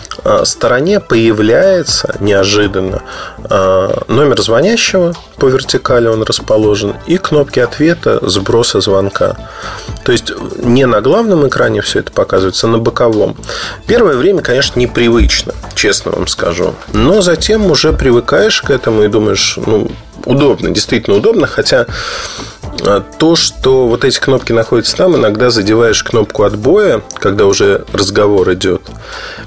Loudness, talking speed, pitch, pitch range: -10 LUFS, 125 wpm, 125 Hz, 110-175 Hz